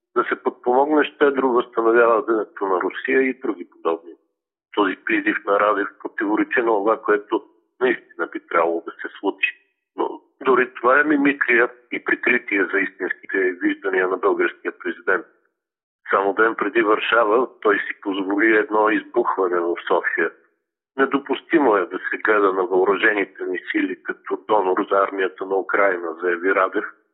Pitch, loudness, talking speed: 345 Hz, -20 LUFS, 145 wpm